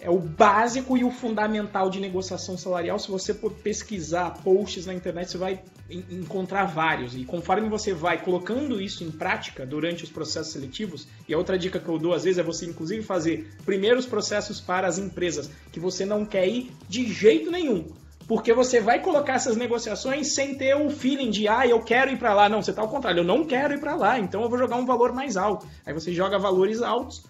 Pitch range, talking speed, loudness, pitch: 180-235 Hz, 220 wpm, -25 LUFS, 195 Hz